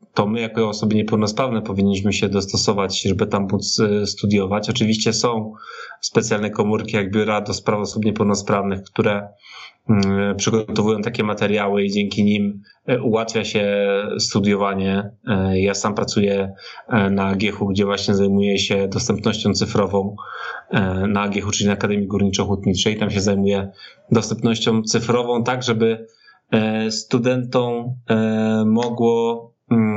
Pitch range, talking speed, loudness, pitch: 100-110 Hz, 115 wpm, -19 LUFS, 105 Hz